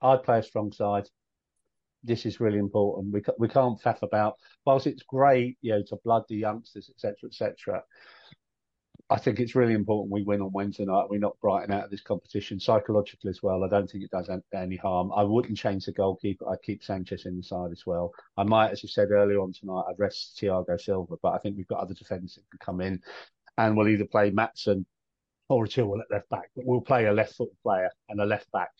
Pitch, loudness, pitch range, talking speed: 105 Hz, -28 LUFS, 100-115 Hz, 230 wpm